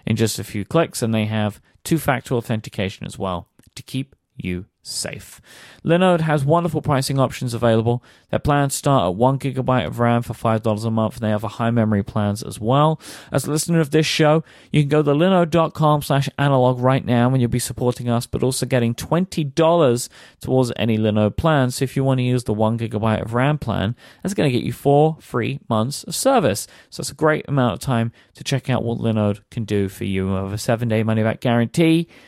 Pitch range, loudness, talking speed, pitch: 110-145 Hz, -20 LUFS, 220 wpm, 125 Hz